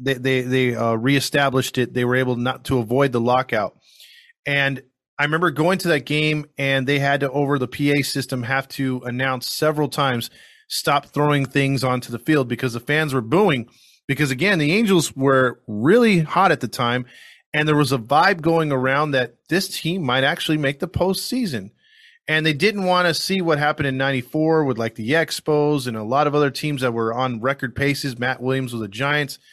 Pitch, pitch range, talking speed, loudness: 140 Hz, 130-155 Hz, 205 wpm, -20 LUFS